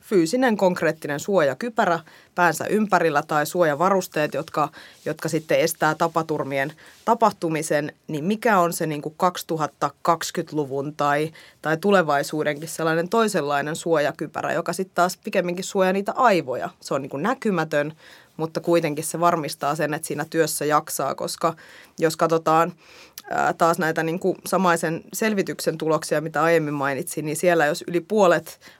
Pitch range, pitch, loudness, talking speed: 150-180 Hz, 165 Hz, -23 LUFS, 135 wpm